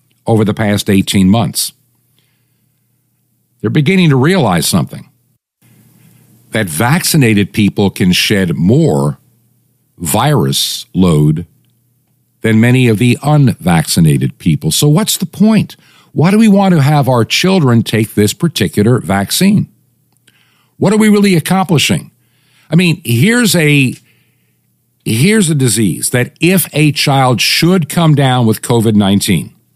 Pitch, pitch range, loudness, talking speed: 130 Hz, 110-160 Hz, -11 LUFS, 125 wpm